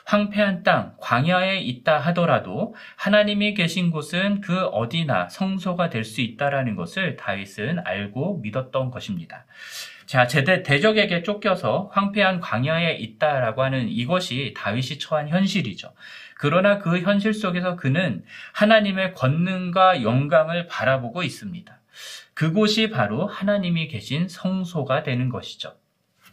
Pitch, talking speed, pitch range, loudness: 170 Hz, 295 characters per minute, 130-190 Hz, -22 LUFS